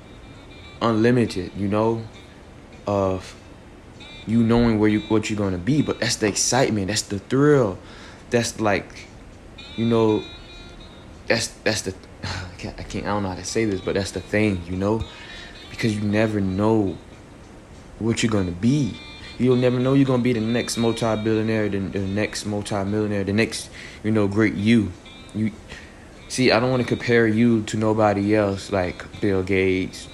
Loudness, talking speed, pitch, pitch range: -22 LUFS, 175 wpm, 105 Hz, 95-115 Hz